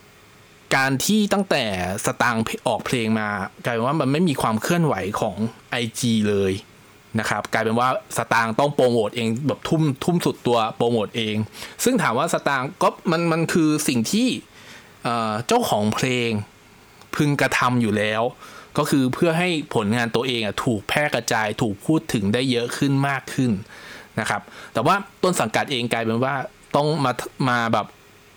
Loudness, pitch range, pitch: -22 LUFS, 110-150 Hz, 125 Hz